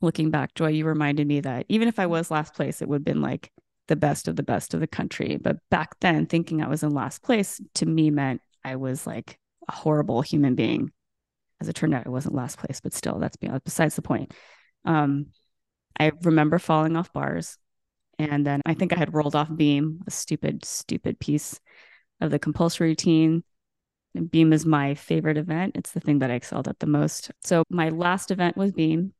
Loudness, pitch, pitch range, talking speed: -25 LUFS, 155 Hz, 145-165 Hz, 210 wpm